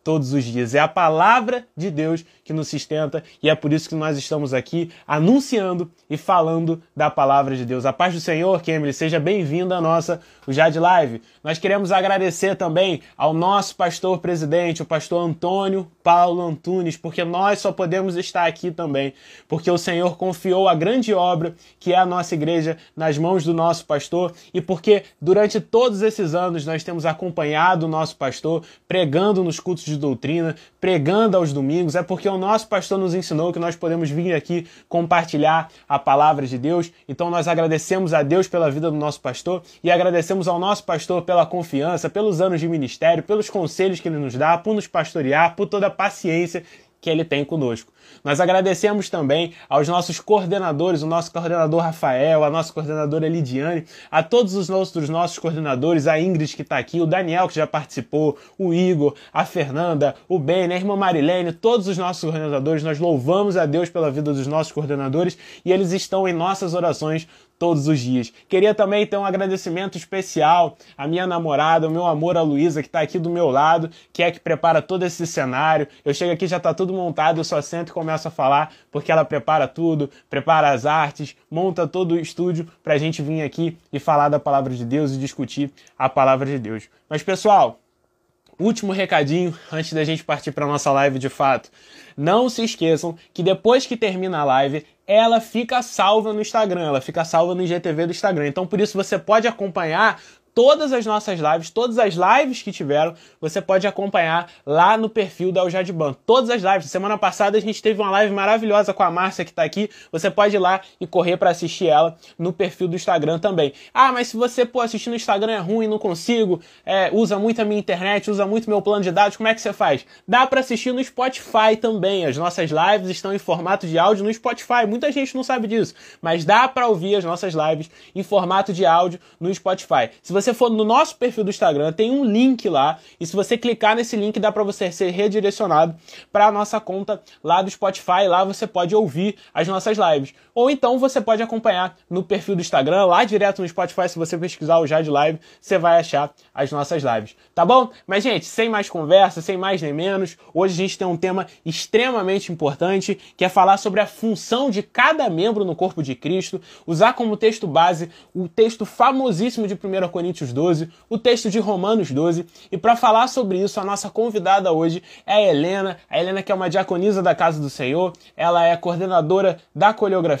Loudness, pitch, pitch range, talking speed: -20 LUFS, 180 Hz, 160-200 Hz, 200 wpm